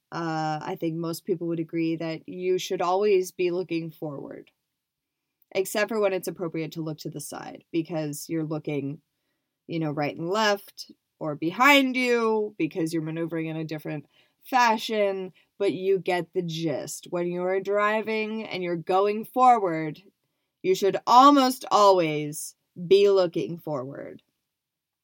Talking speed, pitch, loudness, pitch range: 145 wpm, 170 Hz, -25 LUFS, 155-195 Hz